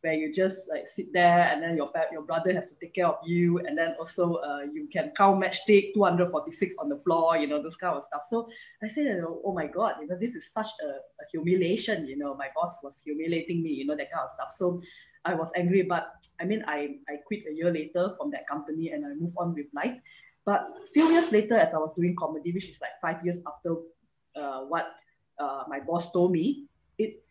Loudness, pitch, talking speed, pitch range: -28 LUFS, 175 Hz, 240 wpm, 160-215 Hz